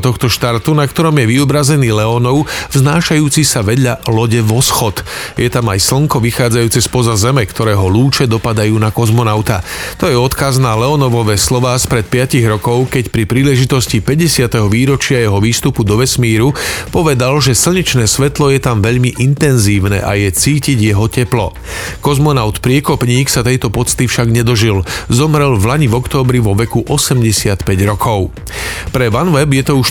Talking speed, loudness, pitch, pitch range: 155 wpm, -12 LUFS, 125 Hz, 110-135 Hz